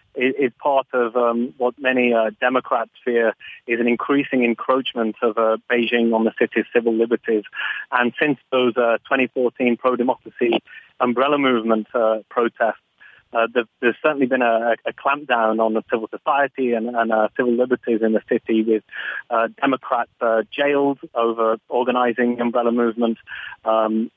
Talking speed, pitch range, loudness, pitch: 150 wpm, 115-130 Hz, -20 LUFS, 120 Hz